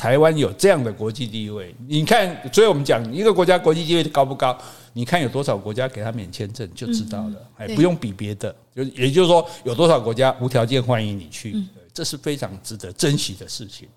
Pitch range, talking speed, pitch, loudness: 110-155 Hz, 335 characters per minute, 125 Hz, -20 LUFS